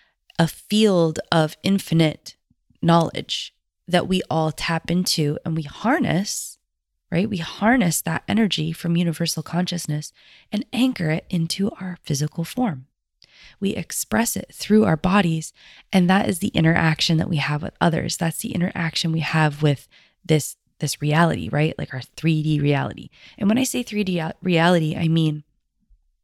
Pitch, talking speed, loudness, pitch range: 165 Hz, 150 wpm, -22 LUFS, 155-185 Hz